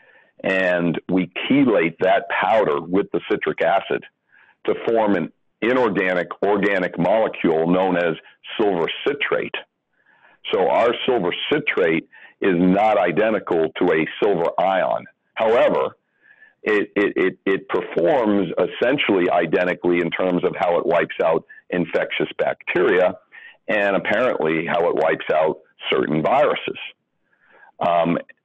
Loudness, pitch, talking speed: -20 LUFS, 95 Hz, 120 wpm